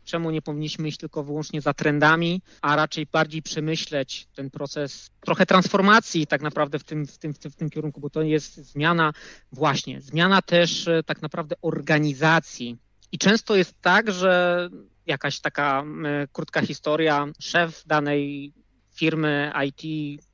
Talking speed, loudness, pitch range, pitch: 150 wpm, -23 LUFS, 145-170 Hz, 155 Hz